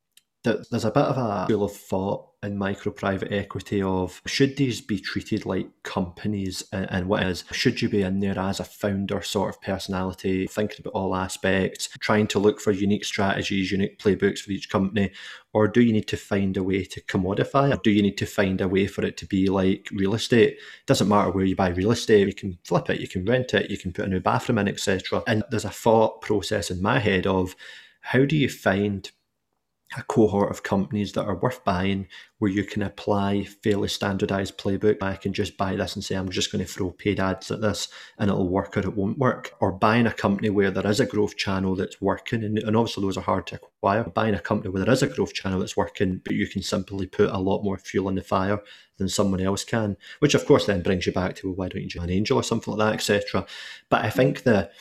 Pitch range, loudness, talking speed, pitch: 95-105 Hz, -24 LUFS, 240 wpm, 100 Hz